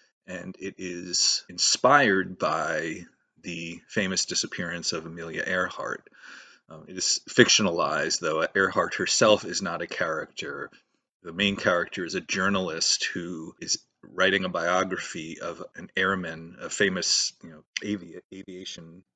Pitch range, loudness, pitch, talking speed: 85-95 Hz, -25 LUFS, 90 Hz, 130 wpm